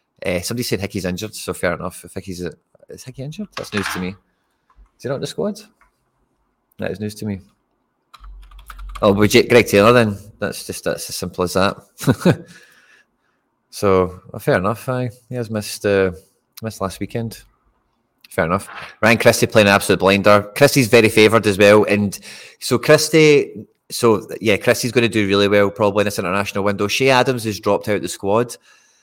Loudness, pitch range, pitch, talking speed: -17 LUFS, 100-120 Hz, 105 Hz, 185 wpm